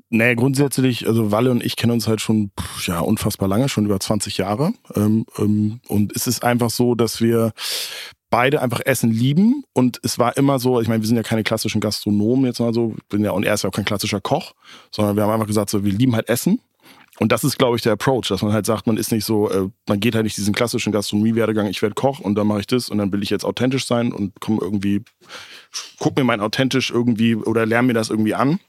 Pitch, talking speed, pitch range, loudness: 110 Hz, 240 wpm, 105-120 Hz, -19 LUFS